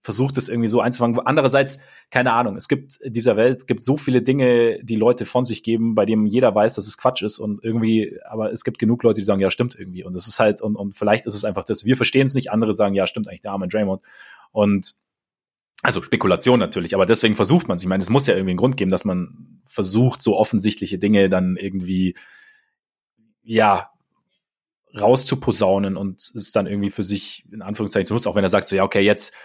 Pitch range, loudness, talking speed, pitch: 100-125 Hz, -19 LUFS, 230 wpm, 110 Hz